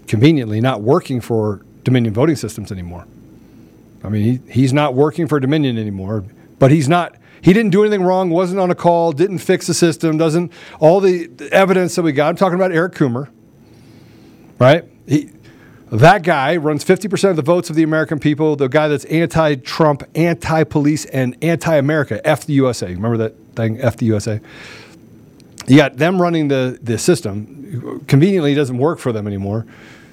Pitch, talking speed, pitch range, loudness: 150 Hz, 175 wpm, 120-165 Hz, -15 LUFS